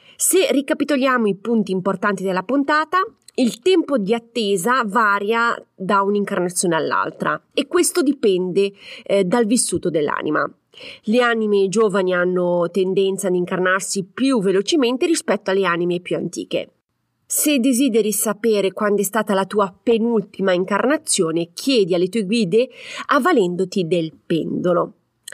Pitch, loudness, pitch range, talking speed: 205 Hz, -19 LUFS, 190-250 Hz, 125 wpm